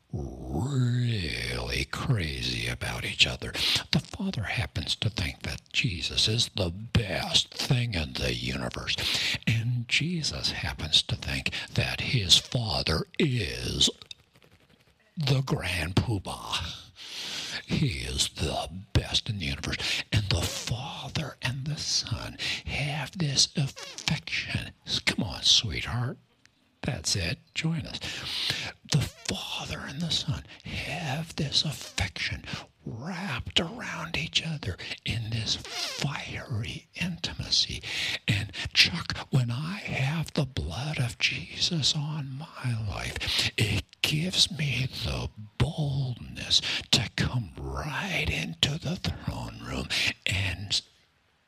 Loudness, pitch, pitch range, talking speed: -28 LUFS, 120 Hz, 90-145 Hz, 110 wpm